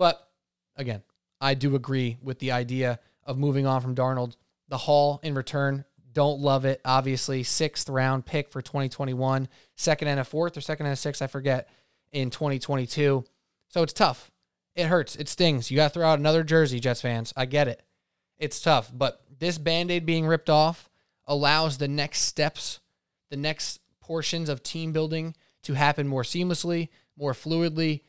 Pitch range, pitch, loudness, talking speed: 130-155 Hz, 145 Hz, -26 LUFS, 175 wpm